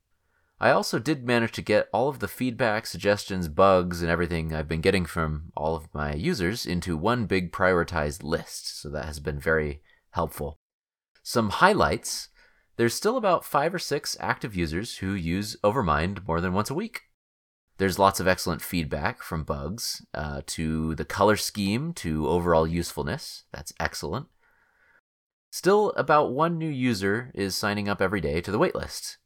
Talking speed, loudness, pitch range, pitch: 165 wpm, -26 LUFS, 80-110 Hz, 95 Hz